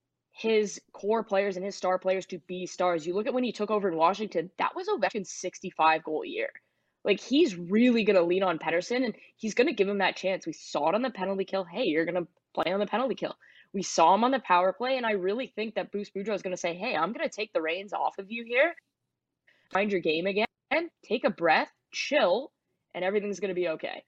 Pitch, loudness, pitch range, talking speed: 195 Hz, -28 LUFS, 180-225 Hz, 245 wpm